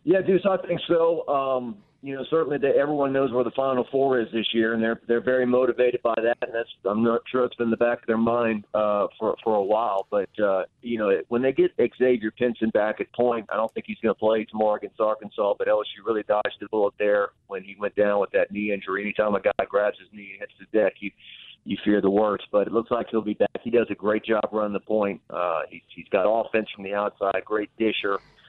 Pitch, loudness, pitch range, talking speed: 115 Hz, -24 LUFS, 105-135 Hz, 255 wpm